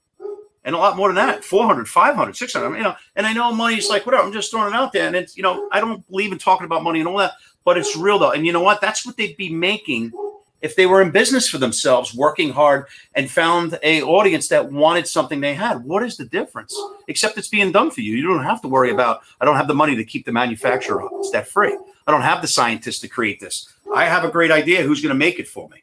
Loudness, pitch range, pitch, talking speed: -18 LUFS, 170-245 Hz, 200 Hz, 270 wpm